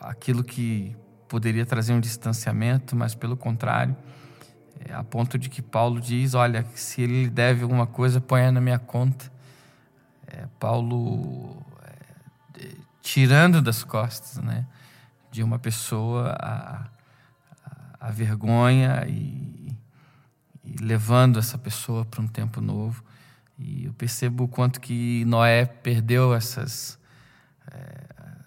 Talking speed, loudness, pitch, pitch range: 125 wpm, -24 LUFS, 125 Hz, 120-135 Hz